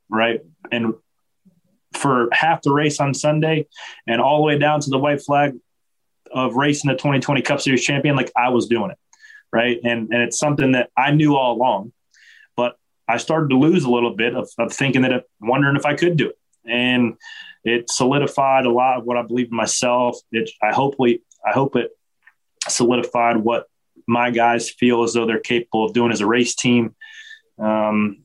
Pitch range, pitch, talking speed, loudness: 120-145 Hz, 125 Hz, 195 wpm, -19 LUFS